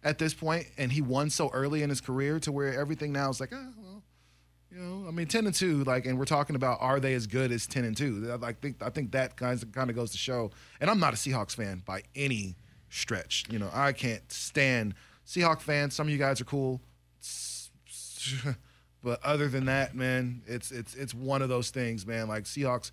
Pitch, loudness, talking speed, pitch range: 130 Hz, -31 LUFS, 230 wpm, 115-145 Hz